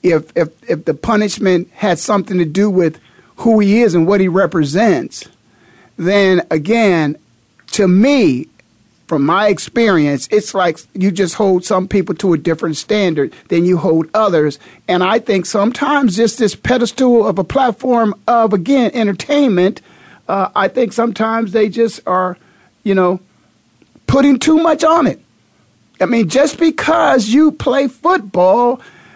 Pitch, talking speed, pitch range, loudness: 205 Hz, 150 wpm, 180-235 Hz, -14 LUFS